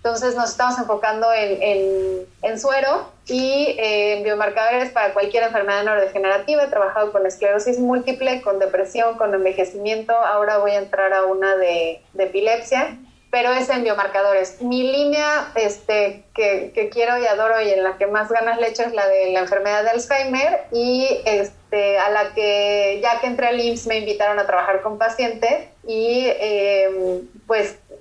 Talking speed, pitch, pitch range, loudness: 170 wpm, 215 Hz, 200-240 Hz, -19 LUFS